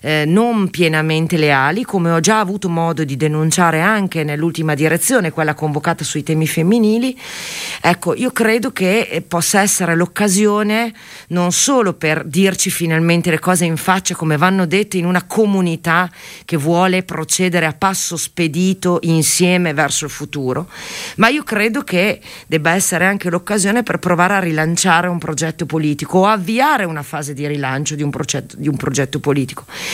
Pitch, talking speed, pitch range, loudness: 170 Hz, 160 wpm, 155-190 Hz, -15 LUFS